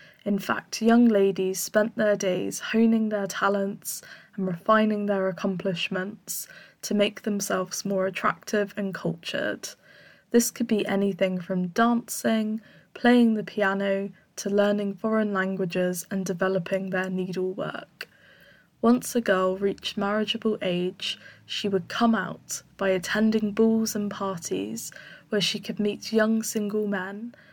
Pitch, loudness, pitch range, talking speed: 200 Hz, -26 LUFS, 190-220 Hz, 130 wpm